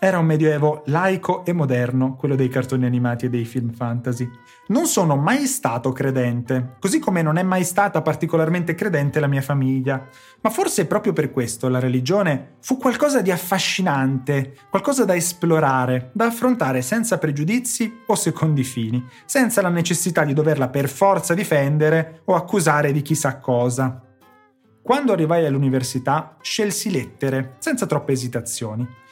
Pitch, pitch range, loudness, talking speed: 150 Hz, 130-190 Hz, -20 LUFS, 150 wpm